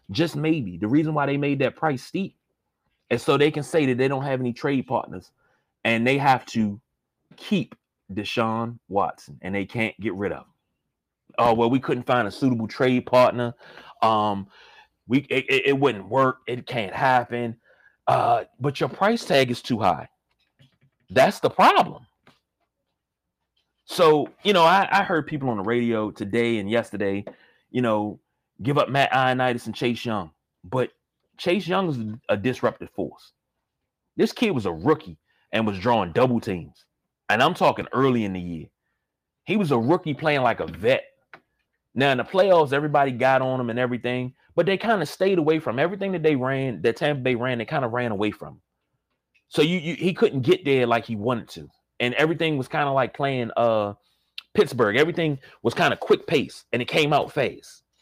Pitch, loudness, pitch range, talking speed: 130 Hz, -23 LUFS, 115-150 Hz, 190 wpm